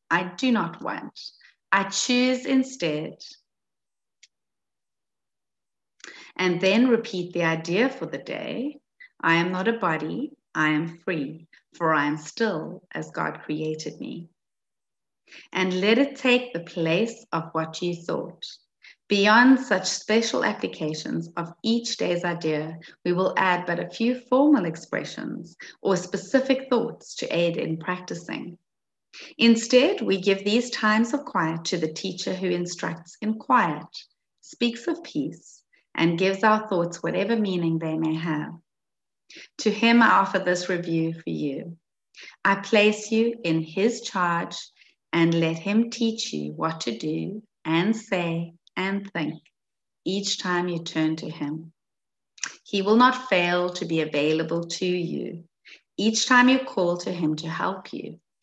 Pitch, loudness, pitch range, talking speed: 180 Hz, -24 LUFS, 165-225 Hz, 145 wpm